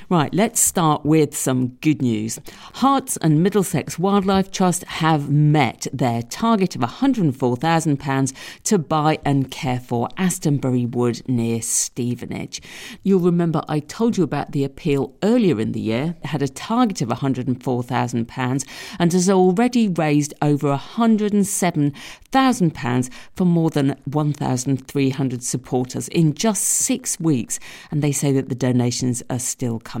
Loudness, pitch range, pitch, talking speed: -20 LUFS, 130-185 Hz, 150 Hz, 140 wpm